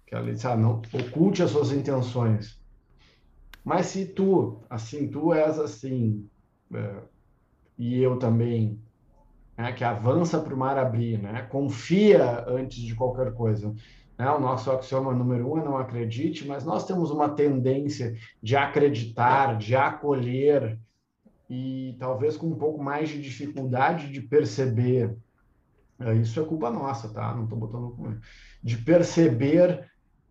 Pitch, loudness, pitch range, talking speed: 130 Hz, -26 LUFS, 115-145 Hz, 145 wpm